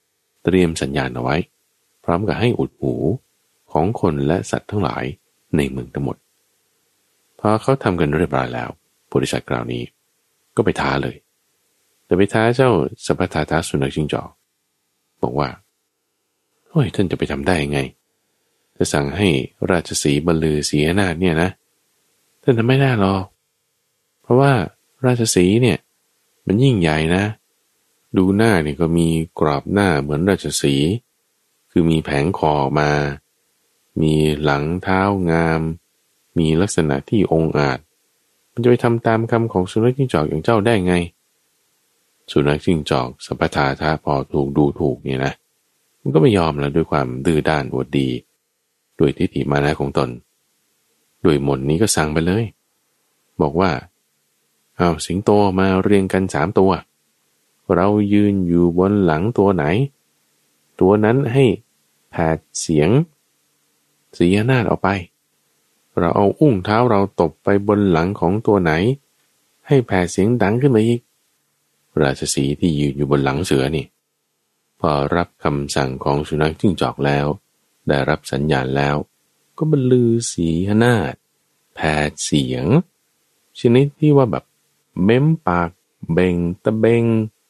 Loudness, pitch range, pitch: -18 LUFS, 75-105 Hz, 85 Hz